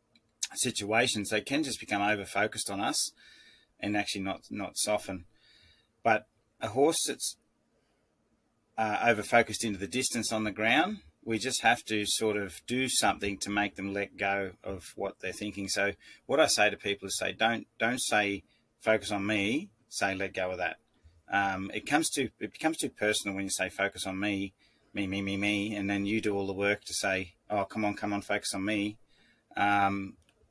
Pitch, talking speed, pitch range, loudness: 100 Hz, 195 wpm, 100-110 Hz, -30 LUFS